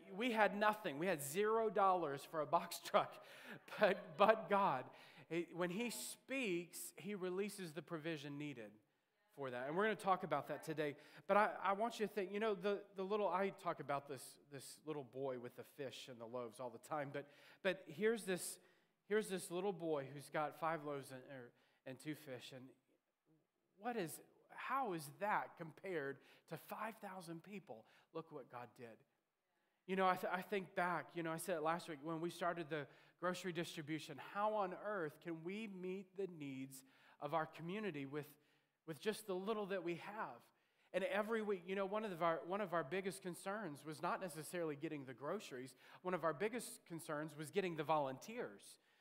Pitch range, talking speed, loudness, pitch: 150-200 Hz, 195 wpm, -43 LUFS, 175 Hz